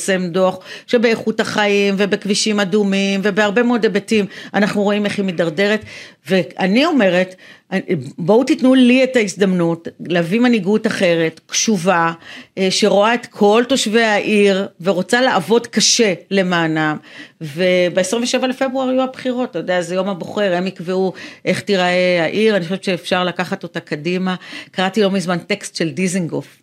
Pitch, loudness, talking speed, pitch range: 195 Hz, -16 LUFS, 135 wpm, 180-220 Hz